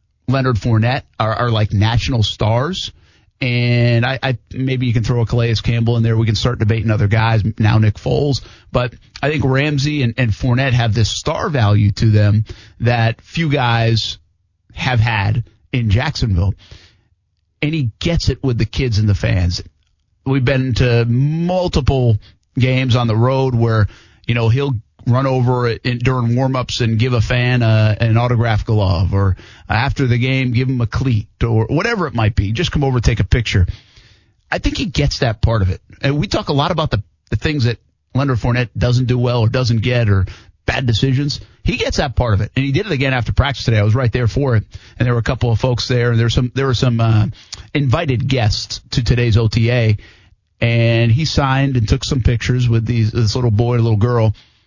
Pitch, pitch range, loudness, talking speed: 115 Hz, 110-130 Hz, -16 LUFS, 205 wpm